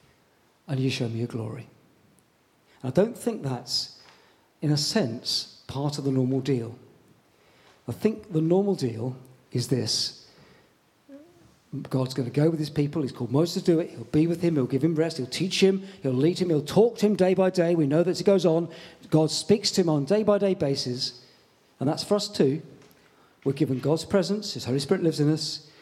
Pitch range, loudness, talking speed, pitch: 130-185 Hz, -25 LUFS, 215 wpm, 155 Hz